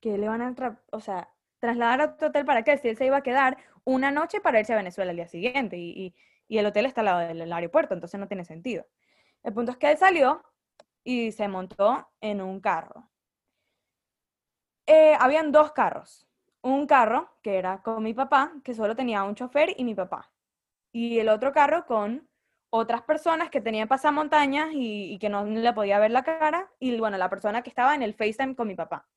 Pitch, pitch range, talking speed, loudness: 240 Hz, 210-290 Hz, 215 wpm, -25 LUFS